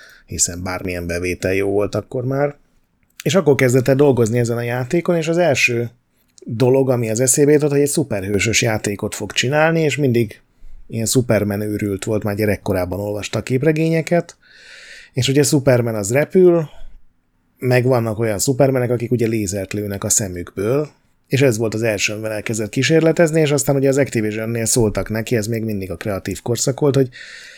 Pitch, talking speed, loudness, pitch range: 120 Hz, 170 wpm, -18 LUFS, 105-140 Hz